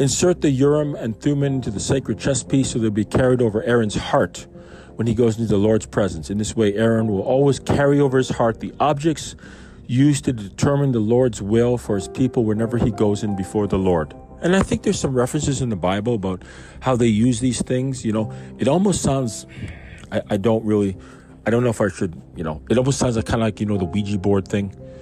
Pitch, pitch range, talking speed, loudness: 115 Hz, 105-130 Hz, 235 wpm, -20 LUFS